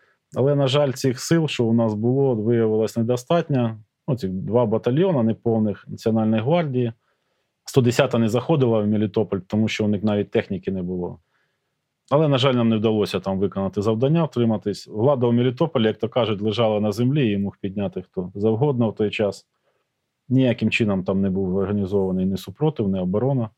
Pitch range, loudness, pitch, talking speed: 105-130 Hz, -21 LUFS, 115 Hz, 175 wpm